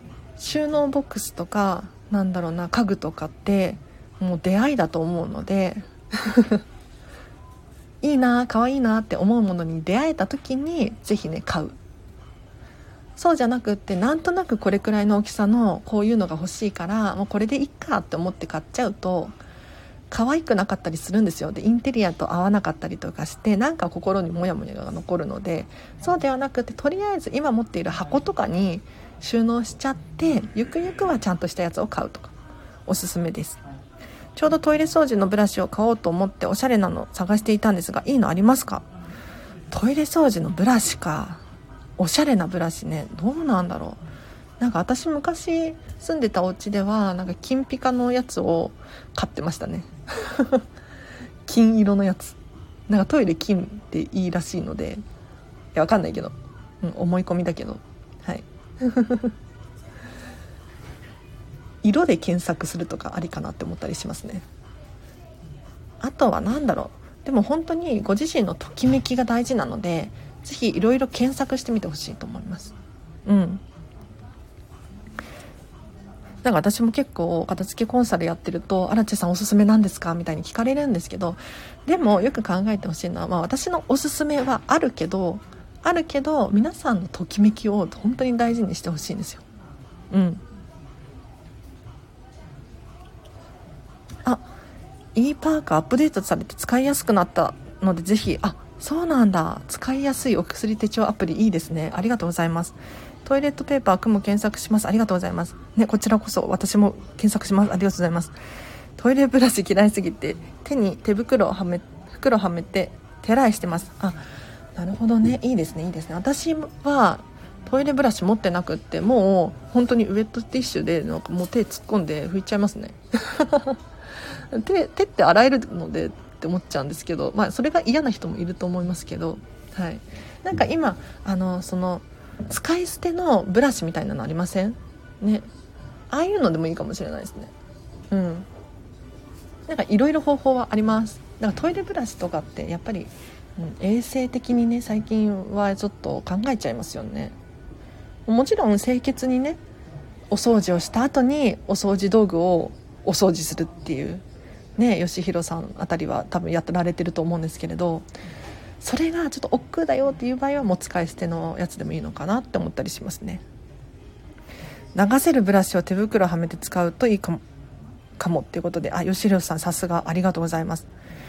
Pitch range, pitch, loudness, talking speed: 175-250 Hz, 205 Hz, -23 LUFS, 355 characters per minute